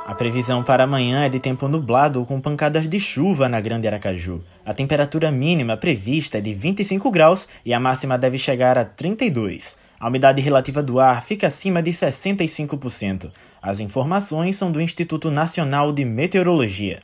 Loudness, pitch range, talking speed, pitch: -20 LUFS, 120-160 Hz, 165 wpm, 135 Hz